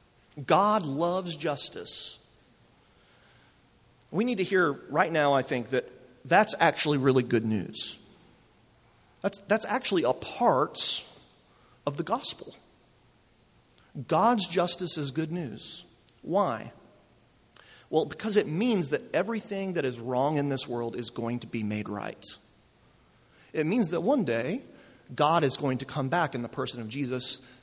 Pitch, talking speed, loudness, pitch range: 140 Hz, 140 wpm, -28 LUFS, 125-175 Hz